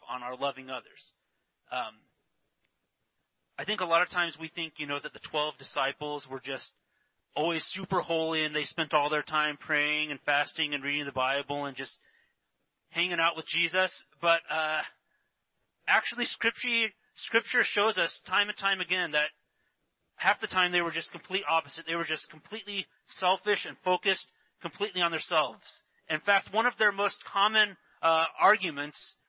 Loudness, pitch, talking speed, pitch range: -29 LUFS, 165 Hz, 170 wpm, 150-185 Hz